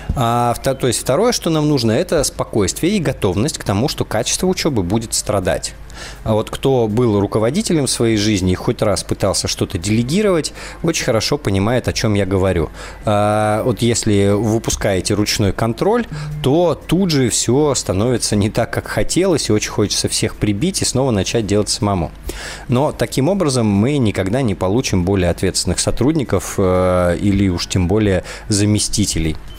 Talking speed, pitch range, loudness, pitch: 160 wpm, 100-135 Hz, -17 LUFS, 110 Hz